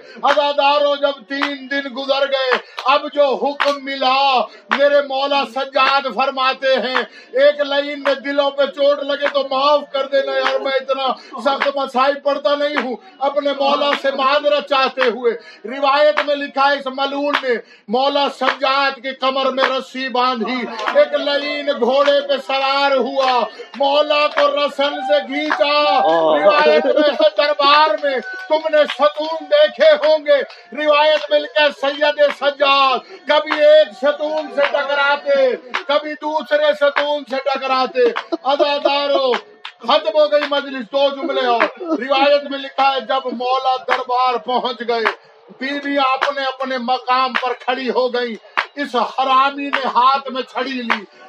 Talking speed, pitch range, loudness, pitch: 145 wpm, 265-290 Hz, -16 LUFS, 280 Hz